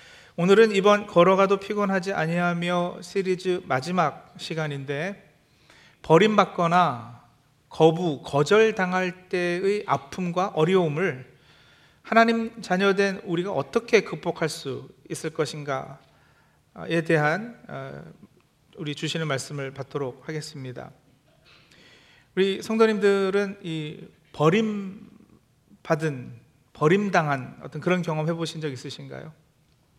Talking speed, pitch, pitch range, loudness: 235 characters per minute, 175 Hz, 150-195 Hz, -24 LUFS